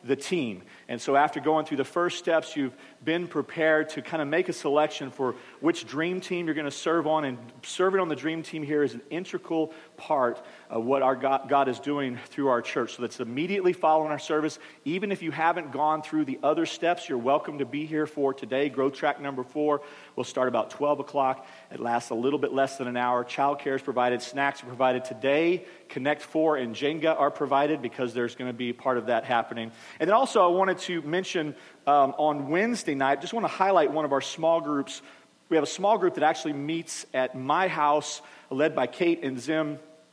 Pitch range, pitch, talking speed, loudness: 135-160 Hz, 150 Hz, 220 wpm, -27 LUFS